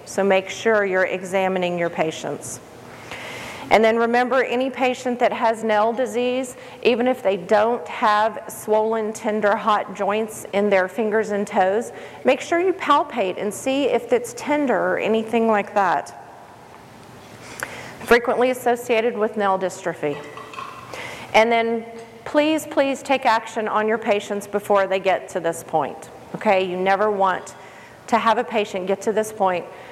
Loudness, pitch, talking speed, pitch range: -21 LUFS, 220 Hz, 150 wpm, 195-240 Hz